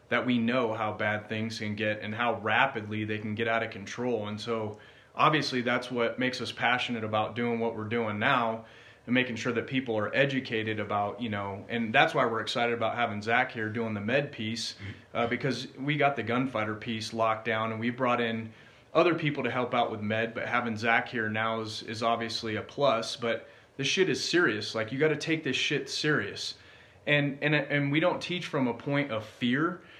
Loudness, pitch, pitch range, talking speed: -29 LUFS, 115 Hz, 110-130 Hz, 215 wpm